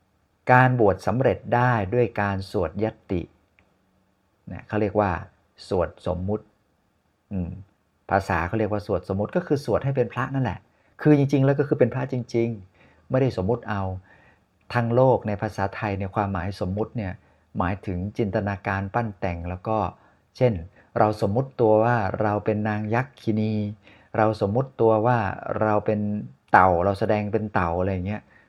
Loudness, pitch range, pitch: -24 LUFS, 95-115 Hz, 105 Hz